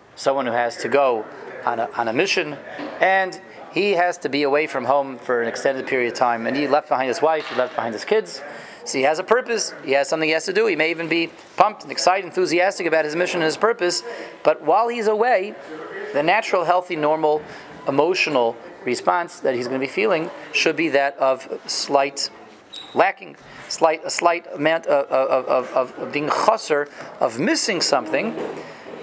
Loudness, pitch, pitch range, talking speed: -20 LUFS, 155 Hz, 135-180 Hz, 200 wpm